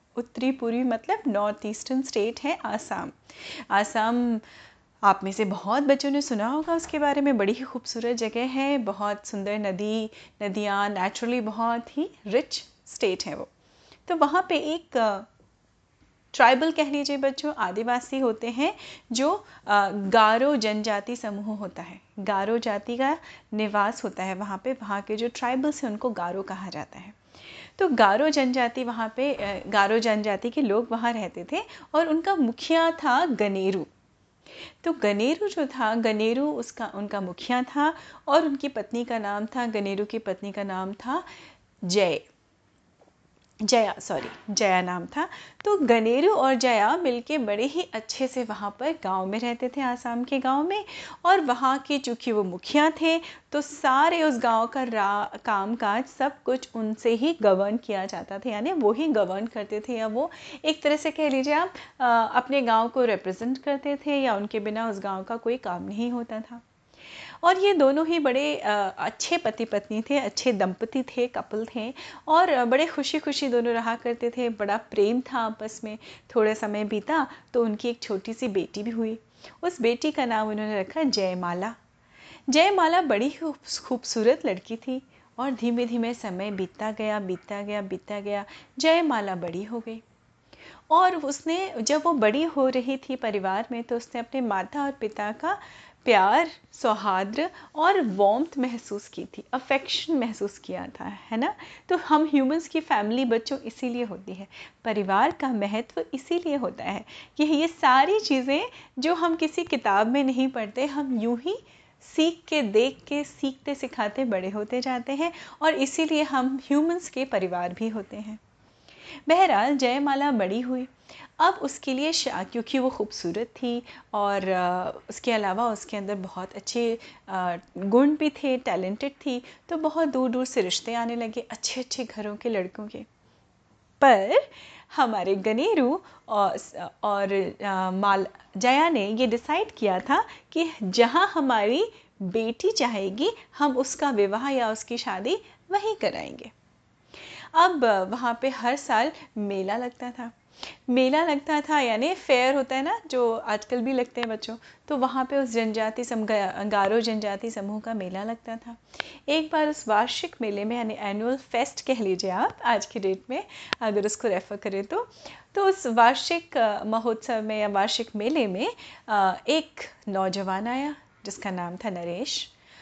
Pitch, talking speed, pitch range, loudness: 240 Hz, 160 wpm, 210-285 Hz, -26 LUFS